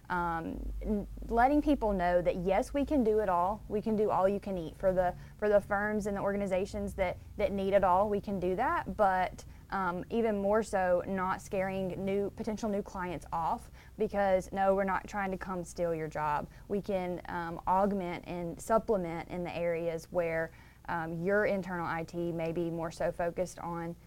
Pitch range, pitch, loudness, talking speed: 175-200 Hz, 190 Hz, -32 LUFS, 190 wpm